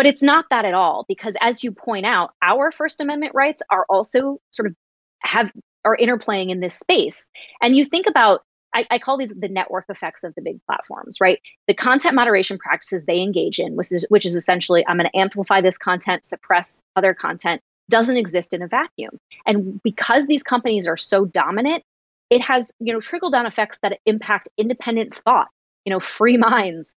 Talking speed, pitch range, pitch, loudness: 200 wpm, 190-255 Hz, 220 Hz, -19 LUFS